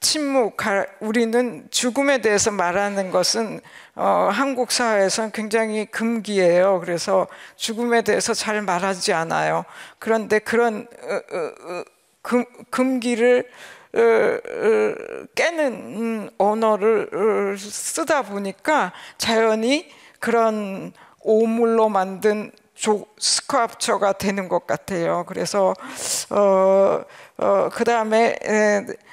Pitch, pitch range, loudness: 225 Hz, 200-245 Hz, -21 LUFS